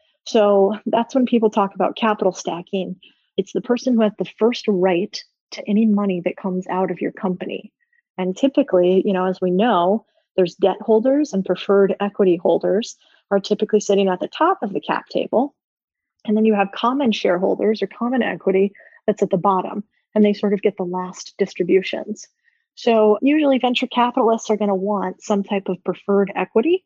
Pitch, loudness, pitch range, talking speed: 205 Hz, -19 LUFS, 190-235 Hz, 185 wpm